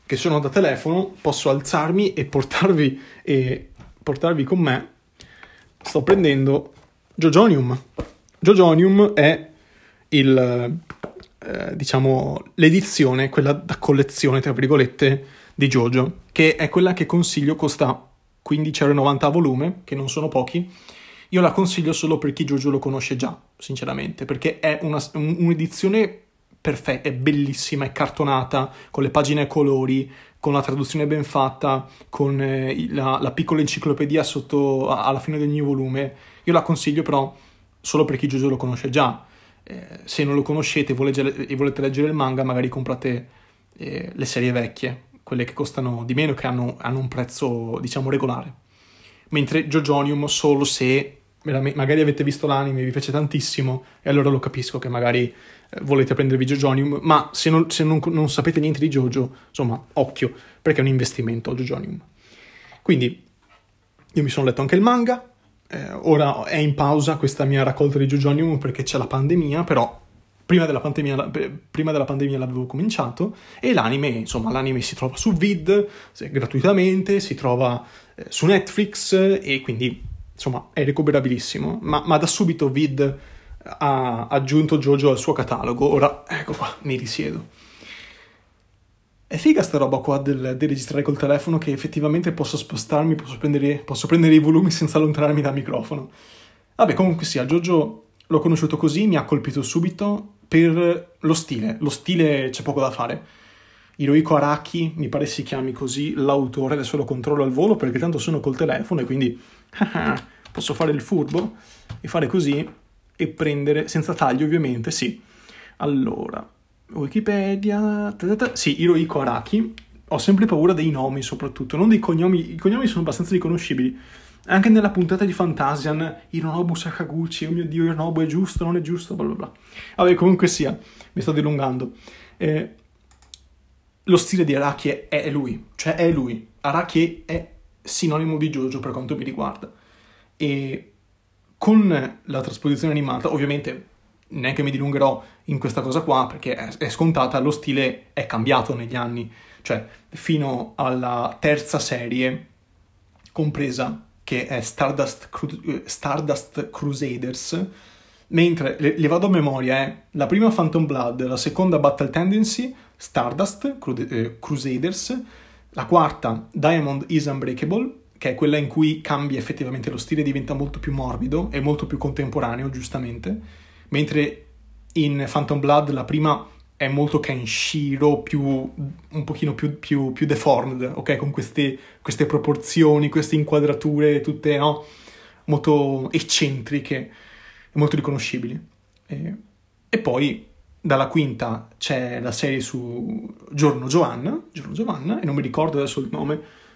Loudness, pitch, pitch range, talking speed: -21 LUFS, 145 Hz, 130-160 Hz, 150 wpm